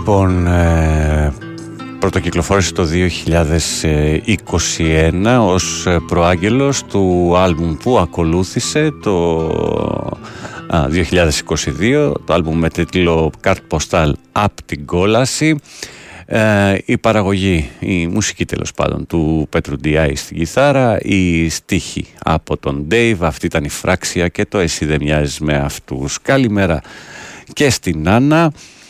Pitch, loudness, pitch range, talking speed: 85 Hz, -15 LUFS, 80-100 Hz, 105 wpm